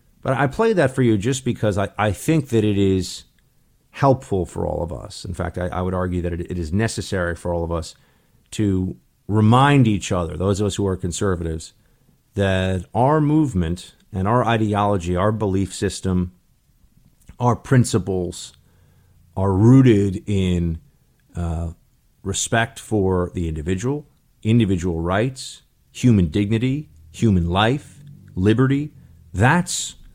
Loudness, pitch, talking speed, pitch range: -20 LUFS, 100 Hz, 140 wpm, 90-120 Hz